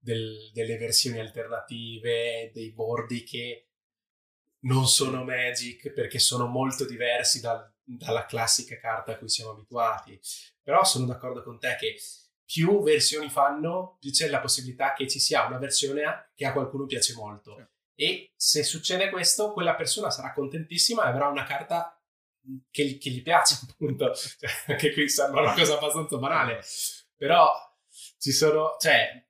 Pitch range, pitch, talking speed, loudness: 120-150 Hz, 135 Hz, 150 wpm, -25 LUFS